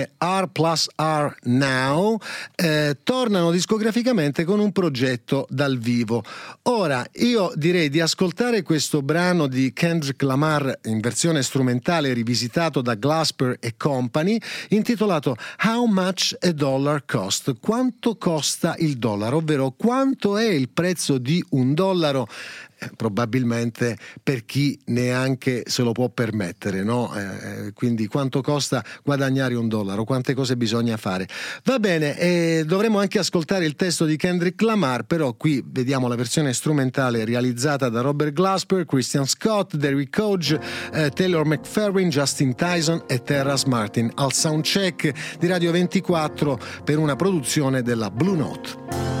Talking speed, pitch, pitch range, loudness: 135 wpm, 150 Hz, 130-180 Hz, -22 LUFS